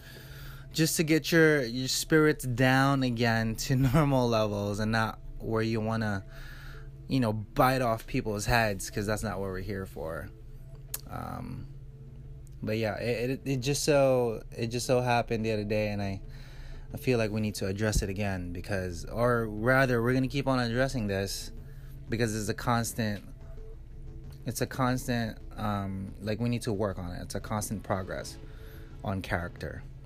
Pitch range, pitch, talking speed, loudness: 105-130 Hz, 120 Hz, 175 wpm, -29 LUFS